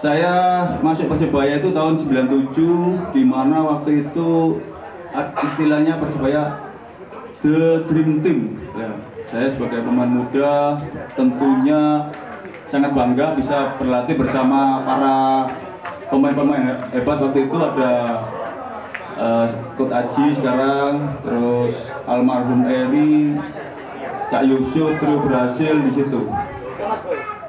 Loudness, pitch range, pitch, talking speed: -18 LUFS, 130-155 Hz, 140 Hz, 100 wpm